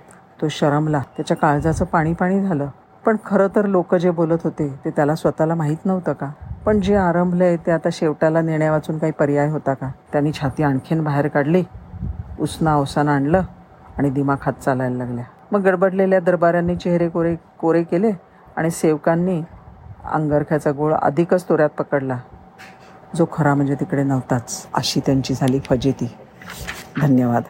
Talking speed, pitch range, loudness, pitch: 150 wpm, 140-170 Hz, -19 LUFS, 155 Hz